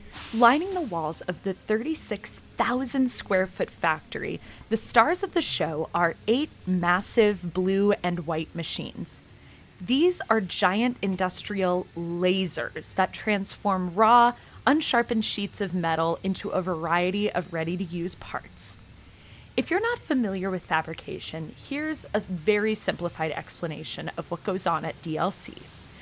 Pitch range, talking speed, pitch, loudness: 175-230 Hz, 135 wpm, 190 Hz, -26 LUFS